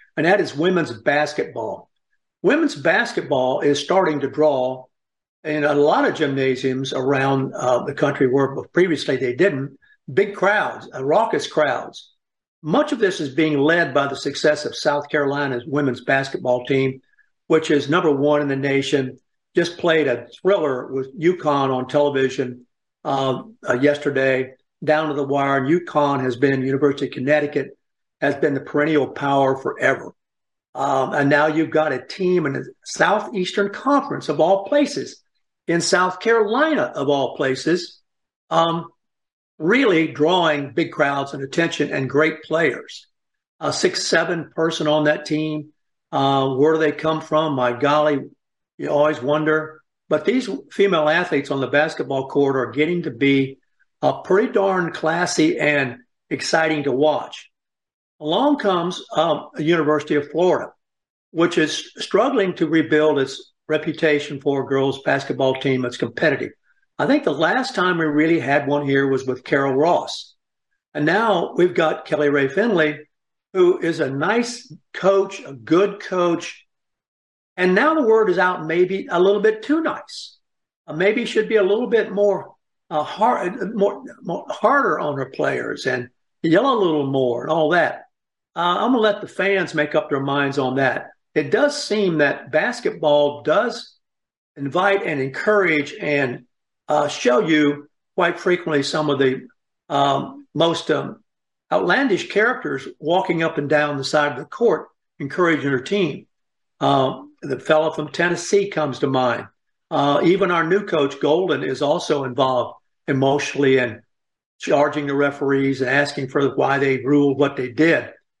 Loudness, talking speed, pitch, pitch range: -20 LUFS, 160 wpm, 150 Hz, 140-175 Hz